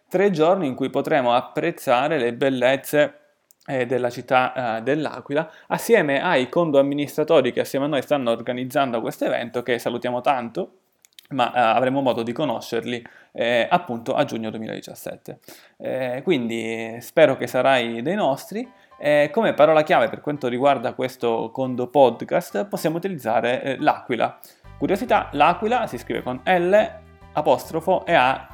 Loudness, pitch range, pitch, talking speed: -21 LUFS, 120-155 Hz, 135 Hz, 145 wpm